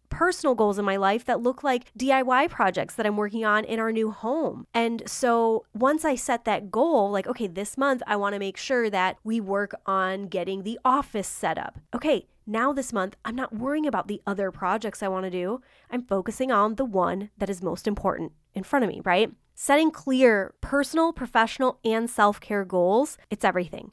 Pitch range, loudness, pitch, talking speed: 200-255 Hz, -25 LUFS, 225 Hz, 205 wpm